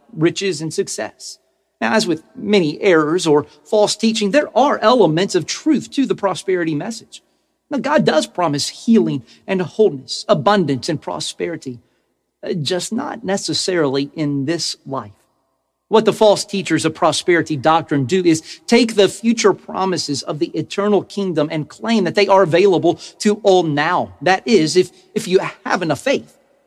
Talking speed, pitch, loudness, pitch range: 155 wpm, 180 Hz, -17 LUFS, 155-205 Hz